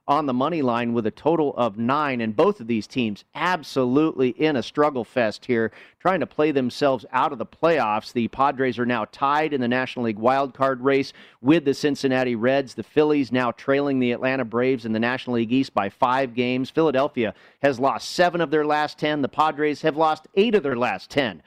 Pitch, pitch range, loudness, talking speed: 130 Hz, 120-150 Hz, -22 LUFS, 210 wpm